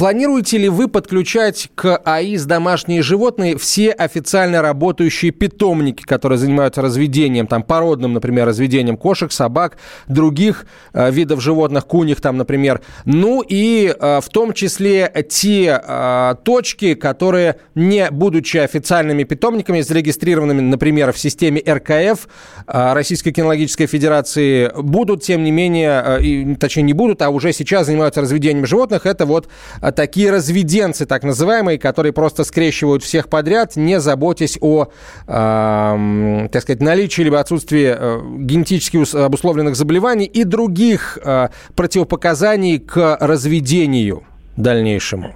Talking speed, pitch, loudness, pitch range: 125 wpm, 155 Hz, -15 LUFS, 140-185 Hz